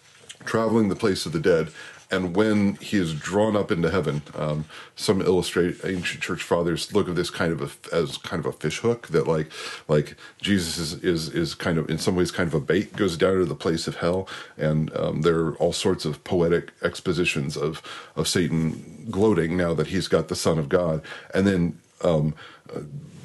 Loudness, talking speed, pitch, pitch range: -24 LUFS, 205 wpm, 90 Hz, 80-100 Hz